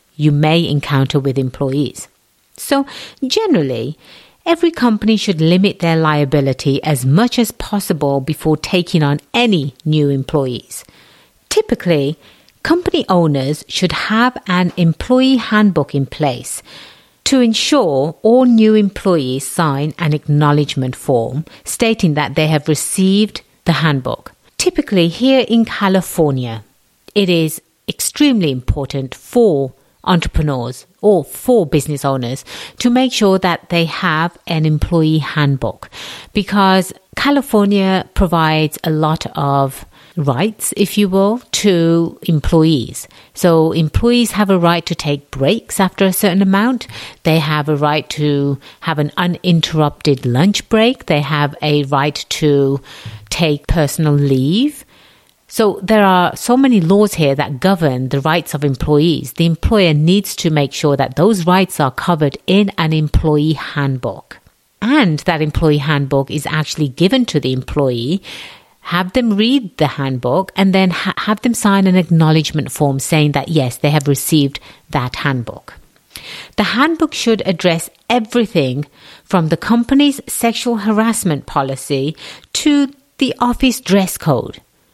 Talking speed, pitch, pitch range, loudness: 135 wpm, 165 Hz, 145-205 Hz, -15 LUFS